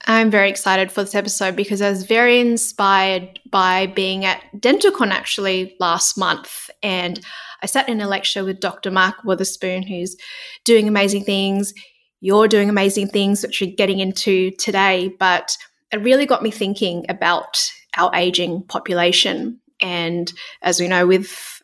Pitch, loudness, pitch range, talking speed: 195 Hz, -18 LUFS, 185-210 Hz, 155 wpm